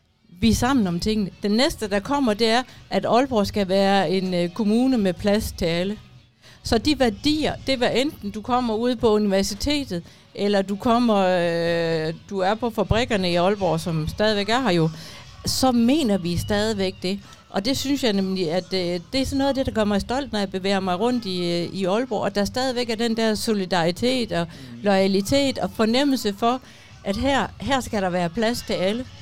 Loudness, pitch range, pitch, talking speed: -22 LUFS, 185-240 Hz, 205 Hz, 205 wpm